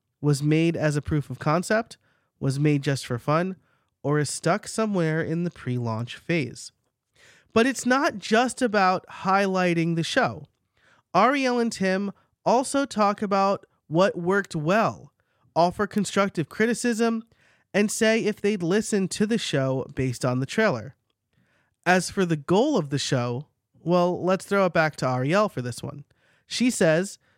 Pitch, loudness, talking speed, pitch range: 175 Hz, -24 LUFS, 155 wpm, 140-205 Hz